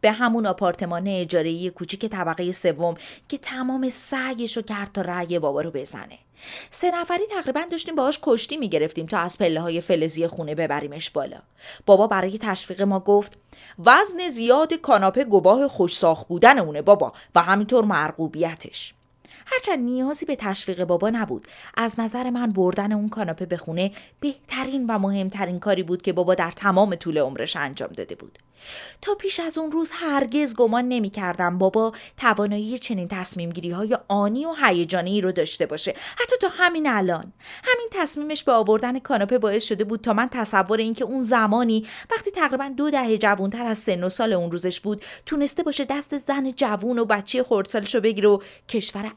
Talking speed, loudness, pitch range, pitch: 170 wpm, -22 LUFS, 185-265 Hz, 215 Hz